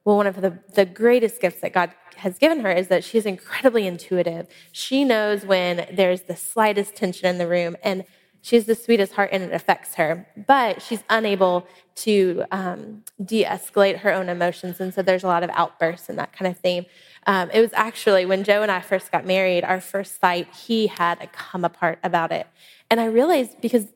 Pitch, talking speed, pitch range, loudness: 190 Hz, 205 wpm, 180-210 Hz, -21 LUFS